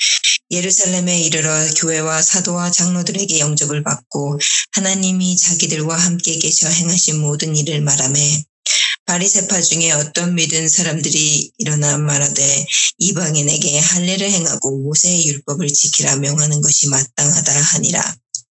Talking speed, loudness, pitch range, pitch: 320 characters per minute, -14 LUFS, 150-175 Hz, 160 Hz